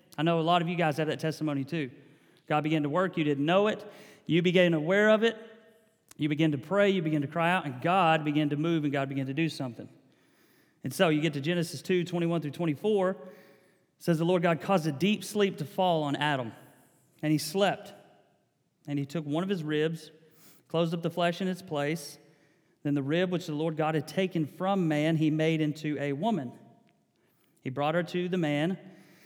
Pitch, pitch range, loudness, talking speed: 160 Hz, 150-180 Hz, -29 LUFS, 215 wpm